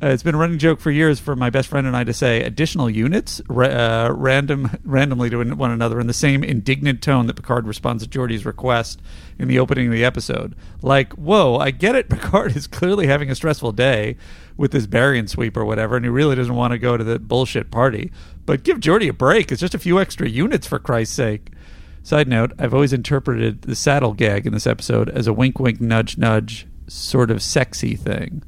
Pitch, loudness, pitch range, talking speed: 125 Hz, -18 LUFS, 115-140 Hz, 220 wpm